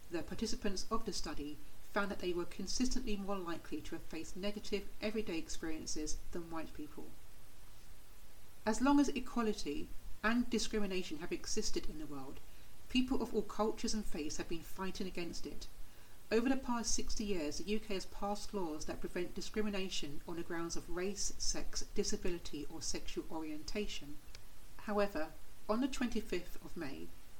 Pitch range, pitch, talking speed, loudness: 155-215 Hz, 190 Hz, 160 wpm, -40 LUFS